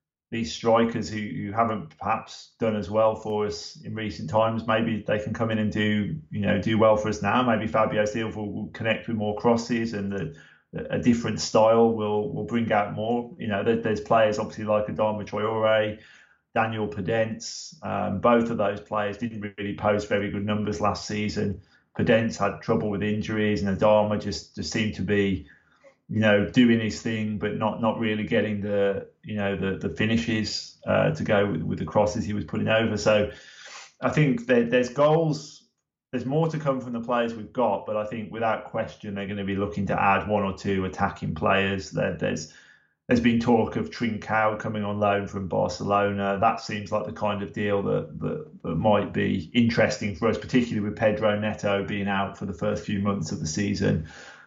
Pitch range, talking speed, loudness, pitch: 105-115 Hz, 200 wpm, -25 LUFS, 105 Hz